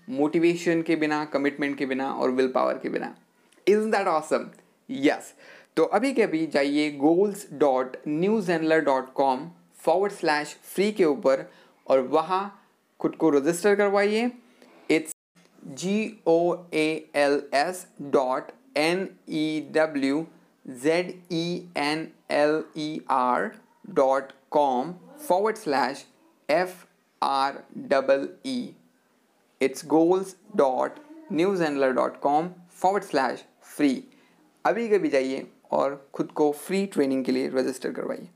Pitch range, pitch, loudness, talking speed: 140-195 Hz, 160 Hz, -25 LUFS, 130 wpm